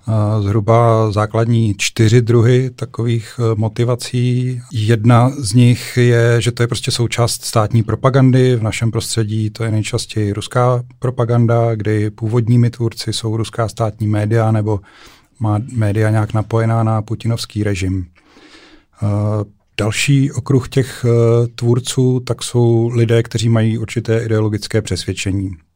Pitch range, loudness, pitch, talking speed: 110-120 Hz, -16 LUFS, 115 Hz, 120 wpm